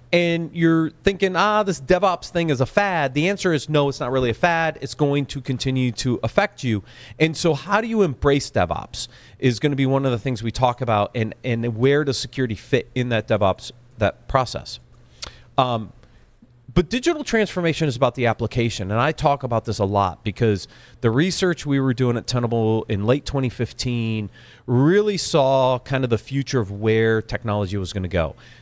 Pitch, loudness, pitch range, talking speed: 130 Hz, -21 LUFS, 115-155 Hz, 195 wpm